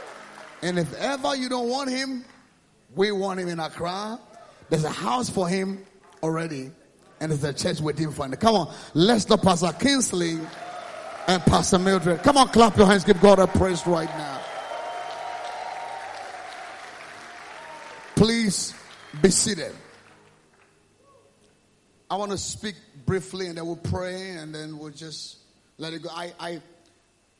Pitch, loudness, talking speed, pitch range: 180 Hz, -23 LUFS, 145 wpm, 160-210 Hz